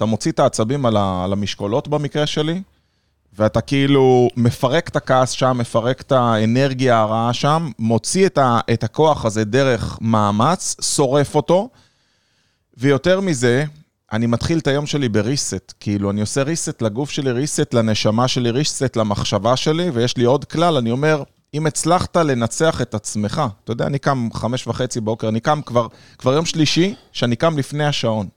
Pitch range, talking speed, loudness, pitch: 115-150 Hz, 165 wpm, -18 LUFS, 130 Hz